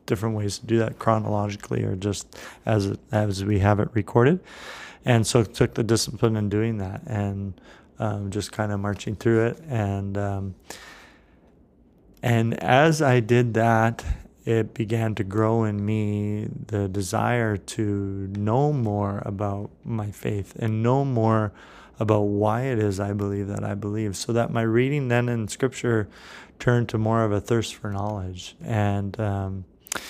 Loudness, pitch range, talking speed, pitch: -24 LUFS, 100-115 Hz, 160 wpm, 110 Hz